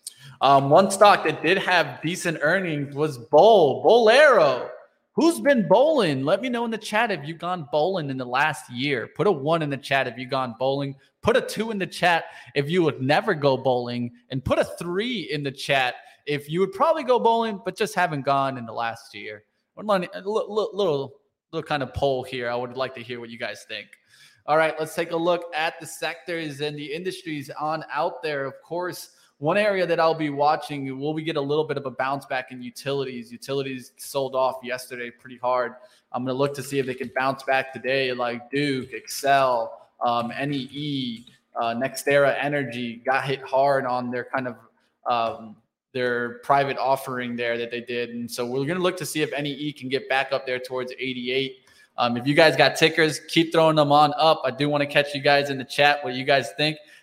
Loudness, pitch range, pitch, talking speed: -23 LUFS, 130-160 Hz, 140 Hz, 220 wpm